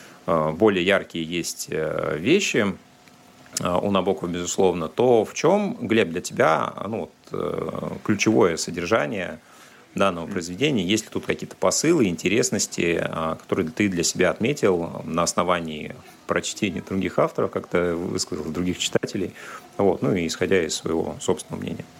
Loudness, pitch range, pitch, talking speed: -23 LUFS, 85-95 Hz, 90 Hz, 130 wpm